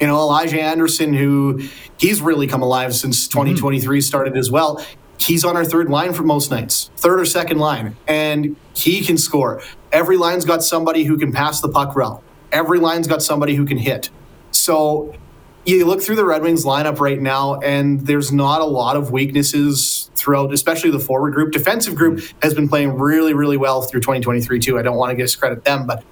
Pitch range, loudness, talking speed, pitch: 135-160 Hz, -16 LUFS, 200 wpm, 145 Hz